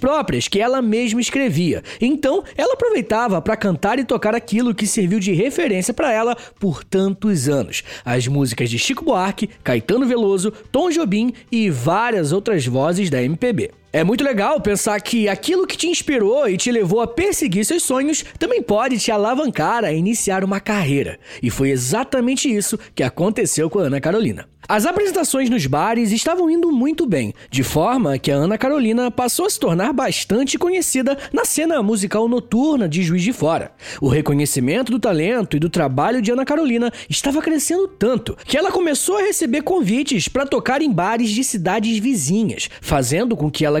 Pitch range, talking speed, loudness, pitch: 190-270 Hz, 175 wpm, -18 LUFS, 225 Hz